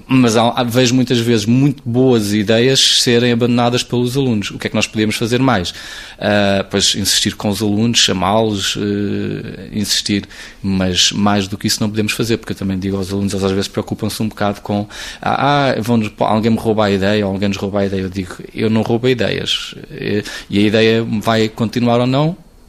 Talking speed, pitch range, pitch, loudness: 195 wpm, 100-120 Hz, 110 Hz, -15 LUFS